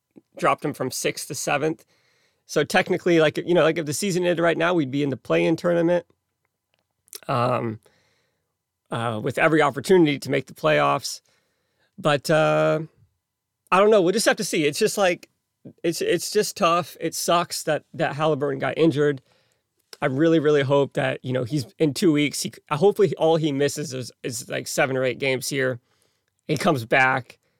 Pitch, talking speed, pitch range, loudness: 155 Hz, 185 wpm, 135-170 Hz, -22 LUFS